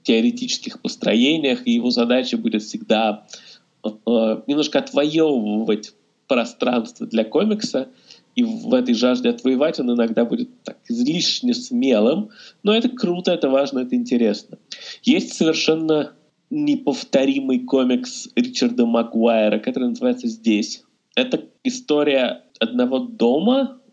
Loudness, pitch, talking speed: -20 LUFS, 160 Hz, 110 wpm